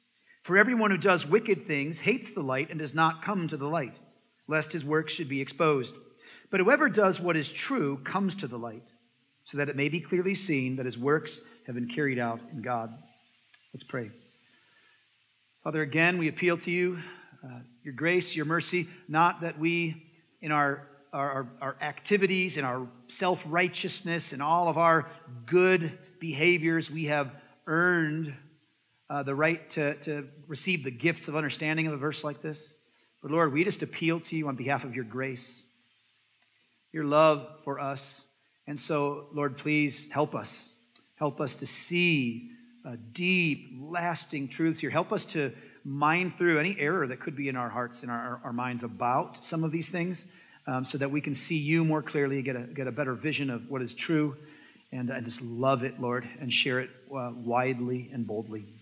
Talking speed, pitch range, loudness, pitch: 185 wpm, 135-165 Hz, -29 LUFS, 150 Hz